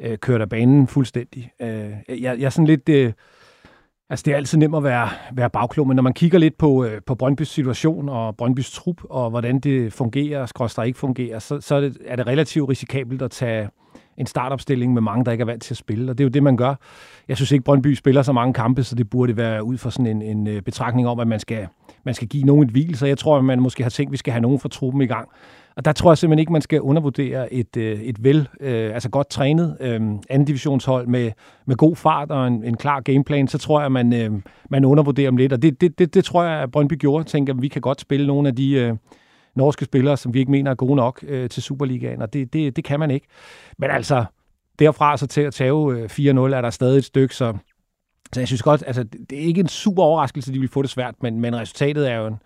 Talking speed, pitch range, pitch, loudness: 245 wpm, 120-145 Hz, 135 Hz, -19 LUFS